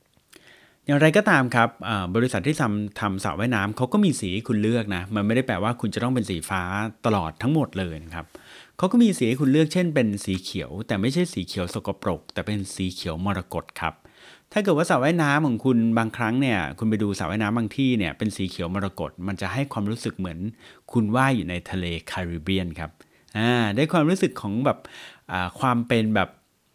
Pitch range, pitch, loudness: 95-125 Hz, 110 Hz, -24 LUFS